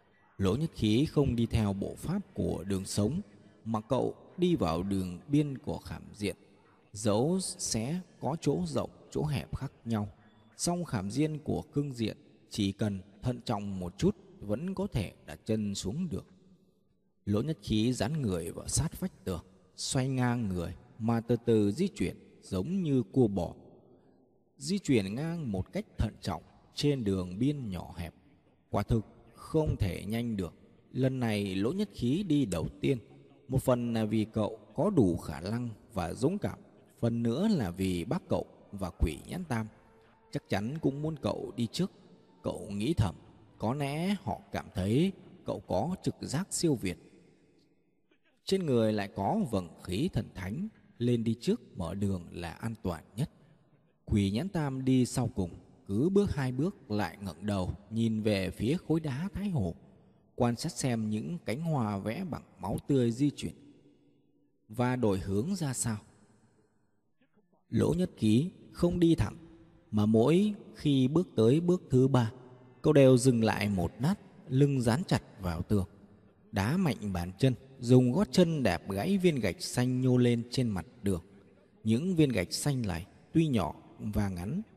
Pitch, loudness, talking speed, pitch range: 115 Hz, -32 LUFS, 170 wpm, 100-150 Hz